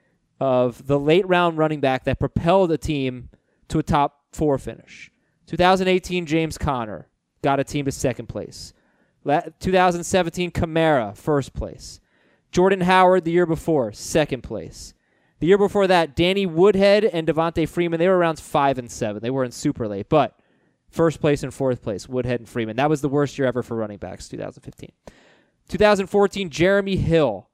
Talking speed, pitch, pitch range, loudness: 165 wpm, 160 Hz, 135-180 Hz, -21 LUFS